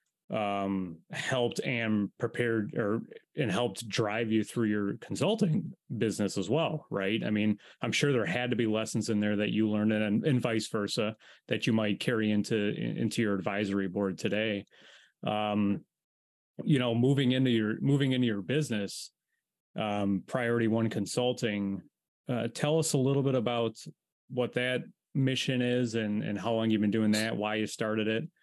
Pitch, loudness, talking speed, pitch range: 110 Hz, -30 LUFS, 170 wpm, 105-125 Hz